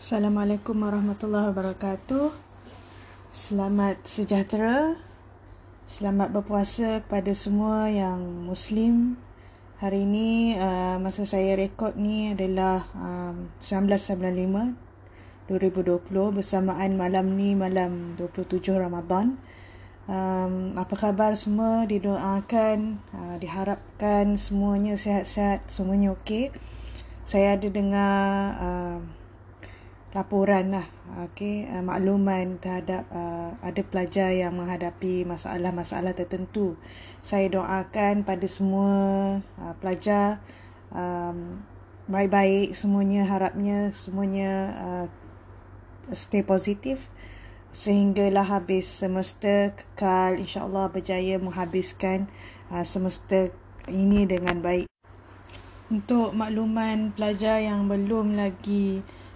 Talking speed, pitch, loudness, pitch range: 85 wpm, 195 Hz, -26 LUFS, 180-205 Hz